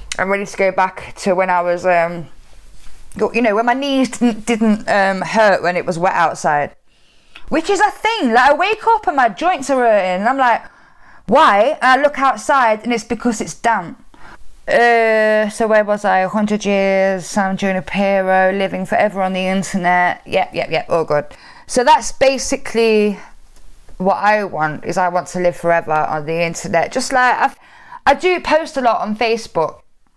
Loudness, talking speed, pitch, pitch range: -15 LUFS, 195 wpm, 215 Hz, 185-250 Hz